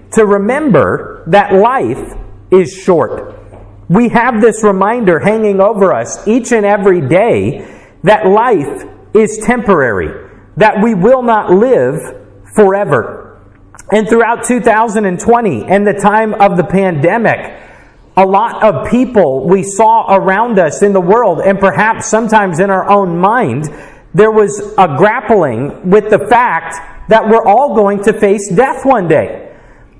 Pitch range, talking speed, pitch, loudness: 190-225 Hz, 140 wpm, 205 Hz, -10 LUFS